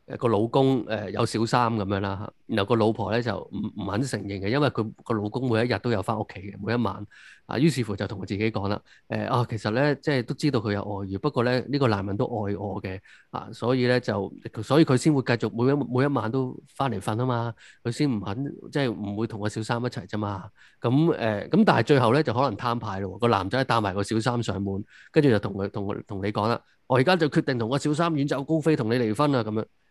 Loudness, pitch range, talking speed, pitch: -26 LUFS, 105-130 Hz, 355 characters per minute, 115 Hz